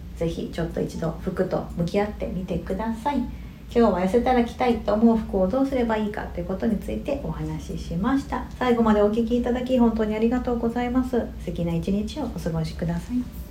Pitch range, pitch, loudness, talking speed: 180-245 Hz, 220 Hz, -24 LUFS, 435 characters per minute